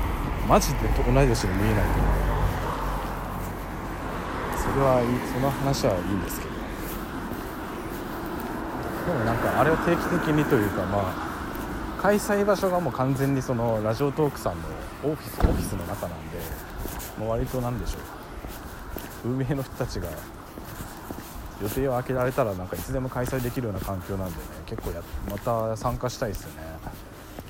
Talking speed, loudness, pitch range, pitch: 310 characters per minute, -27 LUFS, 90-130 Hz, 110 Hz